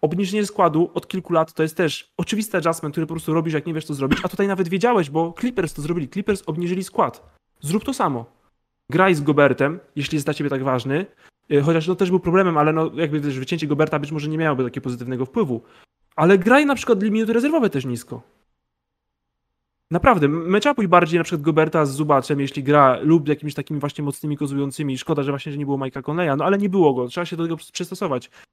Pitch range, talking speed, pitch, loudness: 145-185 Hz, 220 wpm, 160 Hz, -20 LUFS